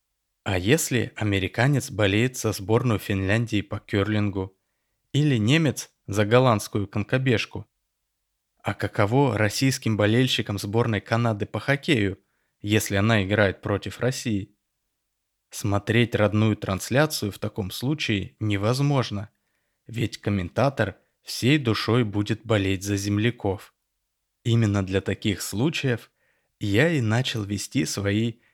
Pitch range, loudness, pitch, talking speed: 100-120 Hz, -24 LUFS, 110 Hz, 105 wpm